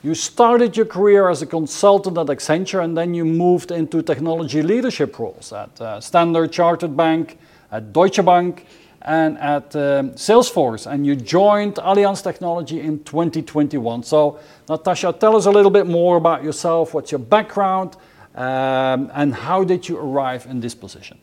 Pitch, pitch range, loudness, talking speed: 165 Hz, 150-185 Hz, -17 LUFS, 160 wpm